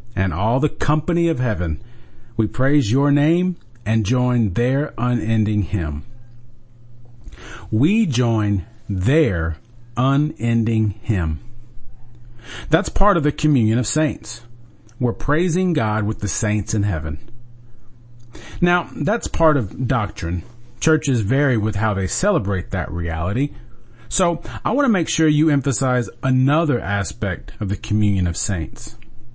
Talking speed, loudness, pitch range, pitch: 130 wpm, -20 LUFS, 105-135 Hz, 120 Hz